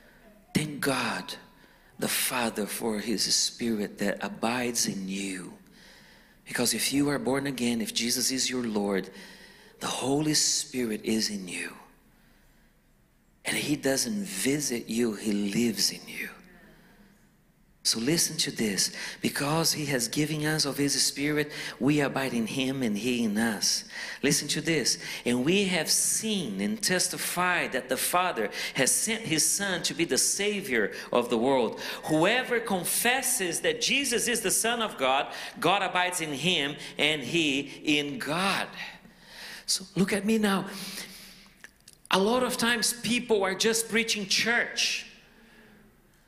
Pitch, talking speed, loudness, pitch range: 160 Hz, 145 wpm, -27 LUFS, 130-200 Hz